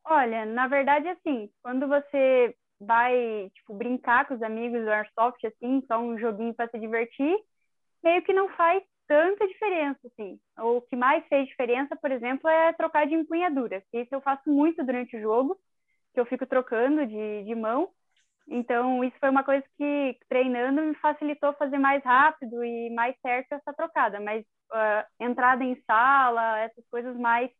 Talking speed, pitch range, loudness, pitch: 175 wpm, 235-290 Hz, -26 LUFS, 255 Hz